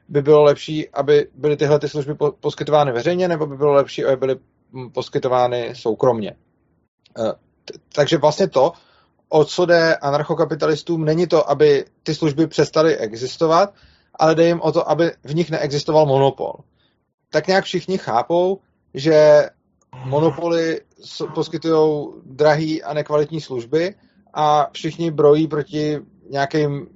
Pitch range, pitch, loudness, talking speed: 145-165 Hz, 155 Hz, -18 LUFS, 130 wpm